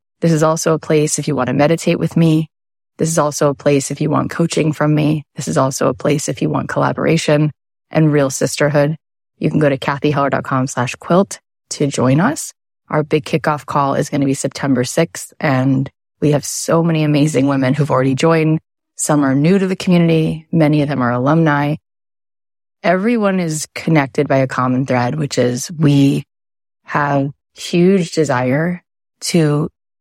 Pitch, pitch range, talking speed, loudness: 150 Hz, 135-160 Hz, 180 wpm, -16 LUFS